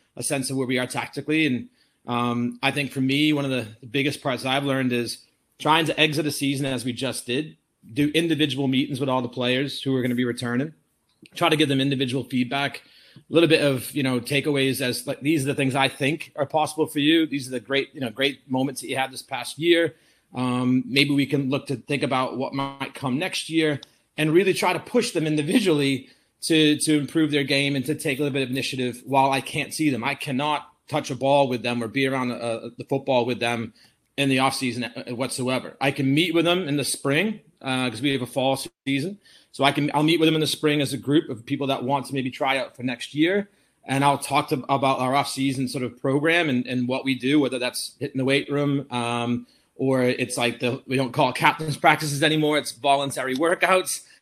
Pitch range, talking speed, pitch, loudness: 130-150 Hz, 240 wpm, 140 Hz, -23 LUFS